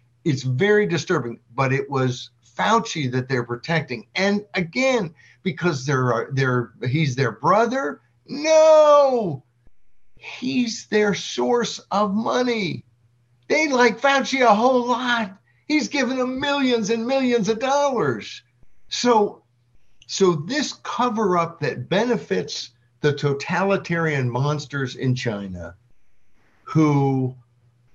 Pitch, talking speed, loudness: 165 Hz, 105 wpm, -21 LUFS